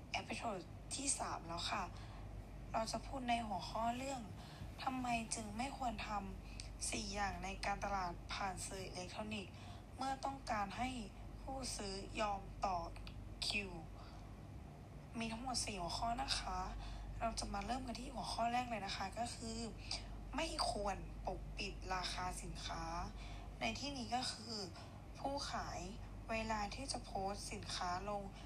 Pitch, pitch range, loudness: 225 Hz, 180-245 Hz, -44 LUFS